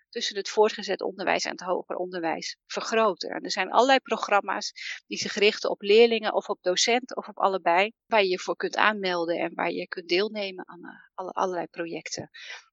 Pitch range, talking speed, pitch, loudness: 180-225 Hz, 190 wpm, 200 Hz, -26 LUFS